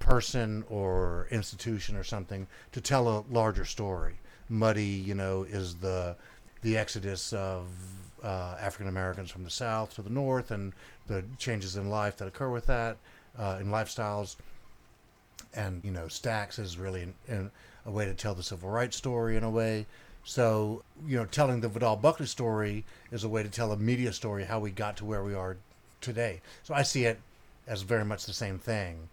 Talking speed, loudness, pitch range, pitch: 190 wpm, -33 LUFS, 95-115 Hz, 105 Hz